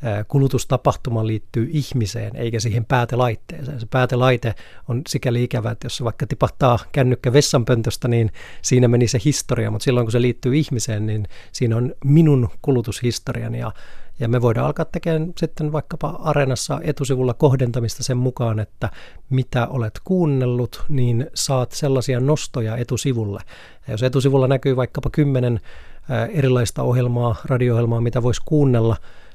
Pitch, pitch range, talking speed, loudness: 125 Hz, 115-140 Hz, 135 wpm, -20 LUFS